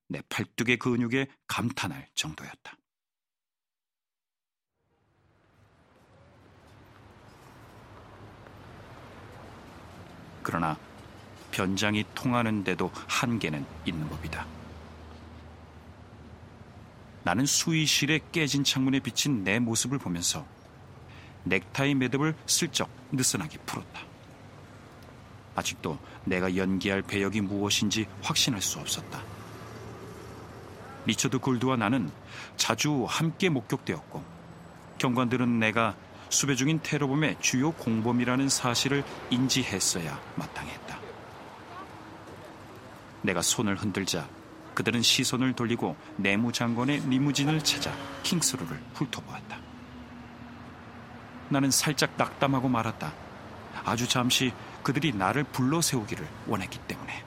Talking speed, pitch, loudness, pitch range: 220 characters per minute, 120 Hz, -28 LUFS, 100-130 Hz